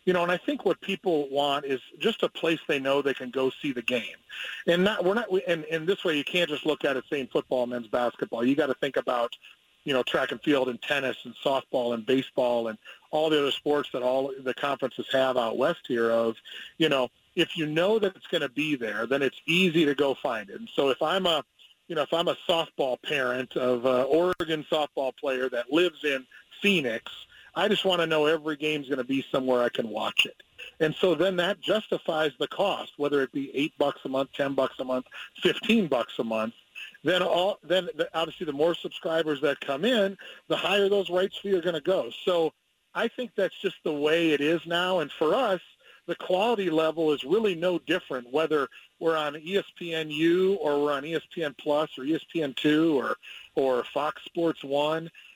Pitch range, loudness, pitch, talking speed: 135-180 Hz, -27 LUFS, 155 Hz, 215 wpm